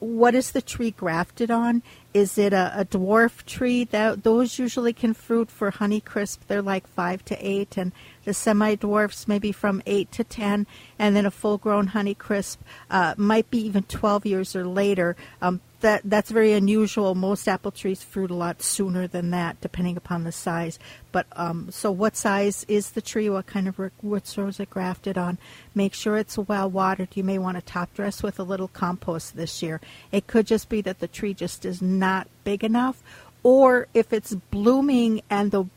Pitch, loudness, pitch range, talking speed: 200 Hz, -24 LUFS, 185-215 Hz, 200 wpm